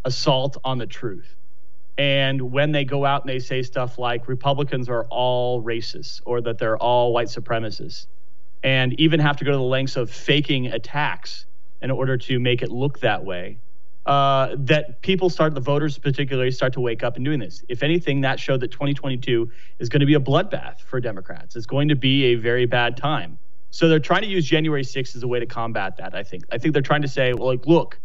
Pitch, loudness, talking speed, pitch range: 130 Hz, -22 LUFS, 220 wpm, 120-145 Hz